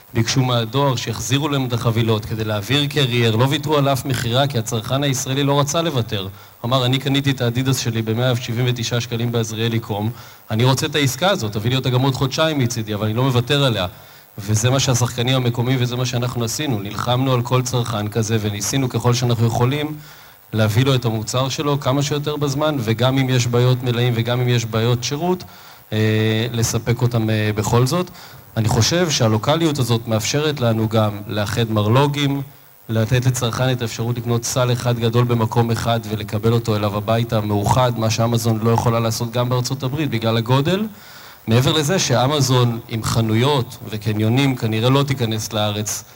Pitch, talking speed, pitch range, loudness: 120 Hz, 170 wpm, 115-135 Hz, -19 LUFS